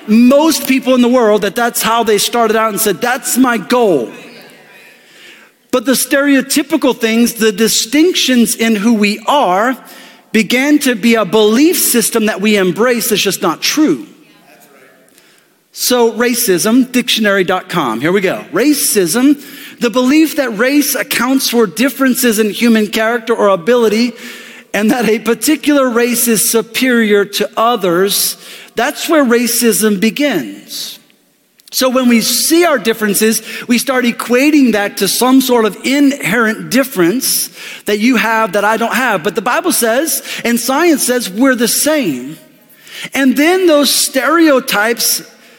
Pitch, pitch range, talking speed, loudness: 240 Hz, 220-270 Hz, 140 wpm, -11 LUFS